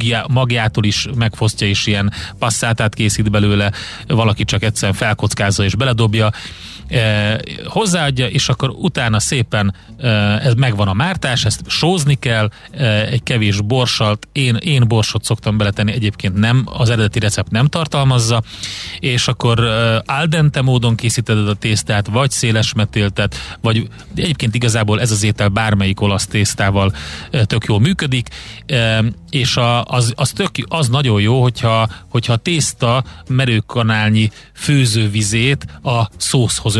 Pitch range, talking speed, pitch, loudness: 105-130 Hz, 130 wpm, 115 Hz, -15 LUFS